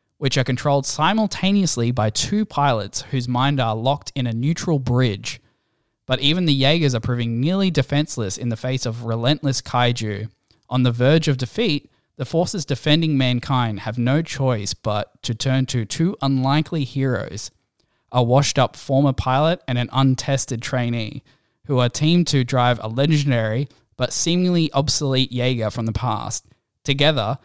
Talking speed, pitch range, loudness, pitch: 155 wpm, 120-145 Hz, -20 LUFS, 130 Hz